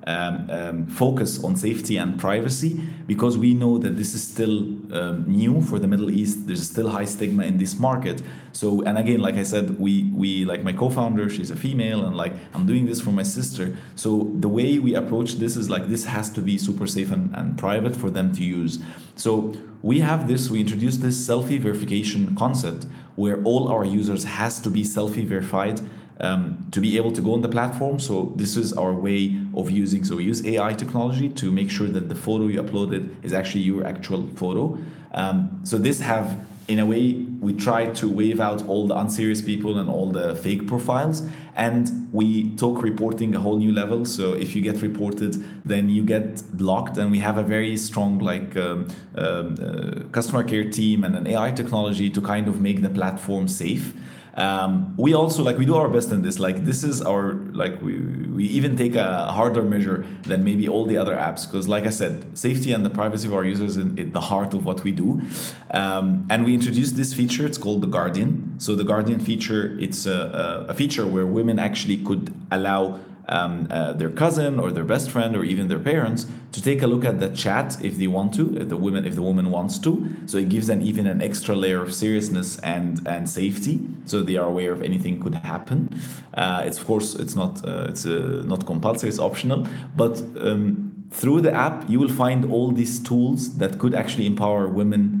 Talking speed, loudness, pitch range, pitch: 210 wpm, -23 LUFS, 100-120 Hz, 105 Hz